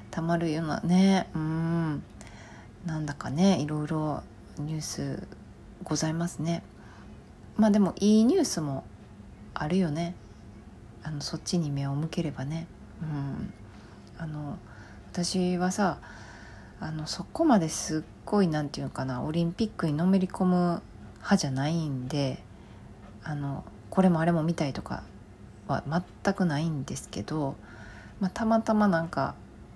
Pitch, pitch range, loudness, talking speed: 155 Hz, 130-175 Hz, -29 LUFS, 265 characters per minute